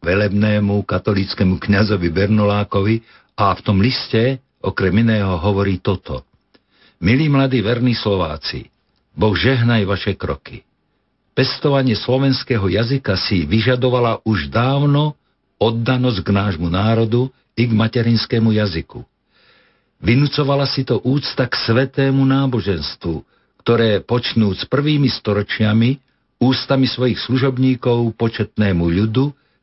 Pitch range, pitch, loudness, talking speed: 100-130 Hz, 115 Hz, -17 LUFS, 105 wpm